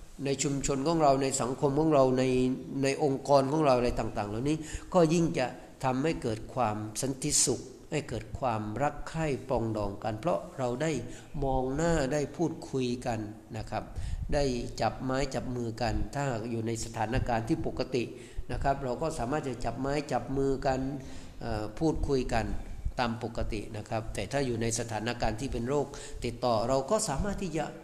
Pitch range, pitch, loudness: 115-145 Hz, 130 Hz, -31 LUFS